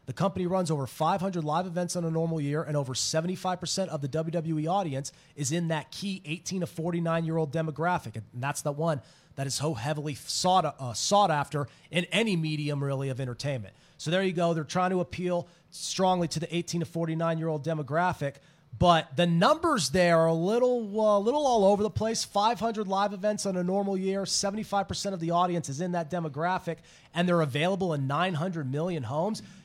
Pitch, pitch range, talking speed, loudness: 170 Hz, 155-185 Hz, 225 wpm, -28 LUFS